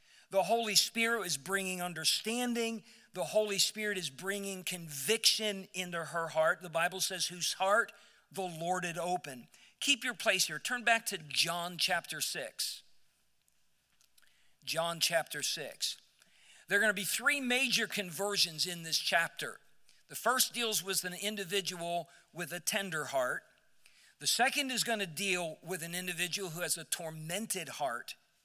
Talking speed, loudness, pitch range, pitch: 150 wpm, -33 LUFS, 170-210 Hz, 185 Hz